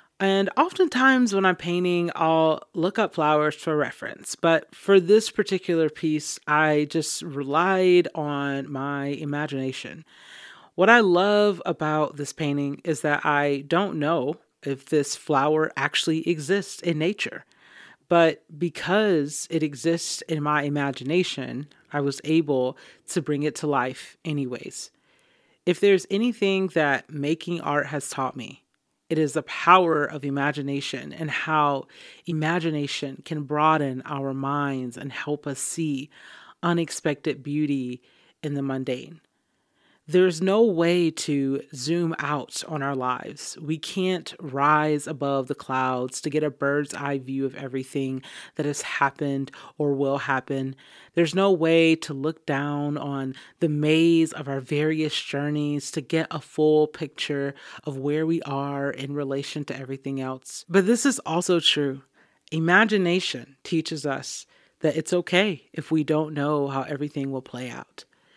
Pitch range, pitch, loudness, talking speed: 140-170 Hz, 150 Hz, -24 LUFS, 145 wpm